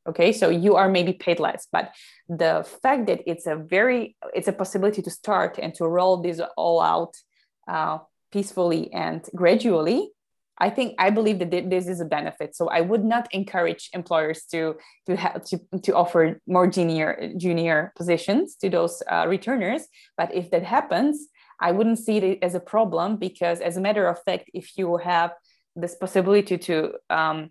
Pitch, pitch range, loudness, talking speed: 180 Hz, 170-200 Hz, -23 LUFS, 180 wpm